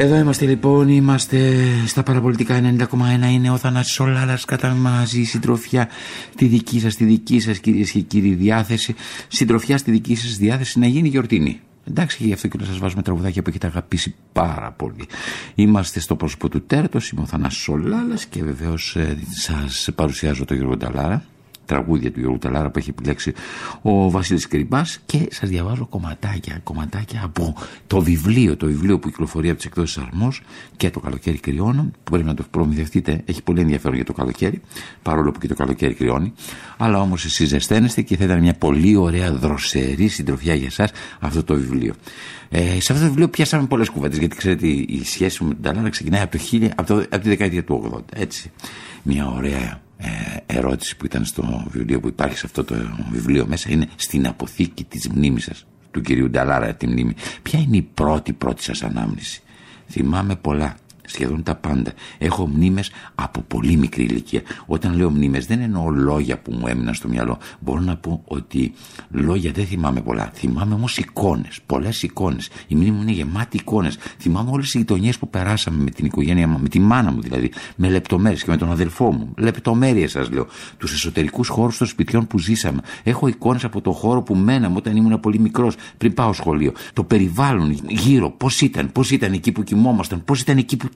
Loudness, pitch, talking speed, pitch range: -20 LUFS, 95 Hz, 185 wpm, 75-115 Hz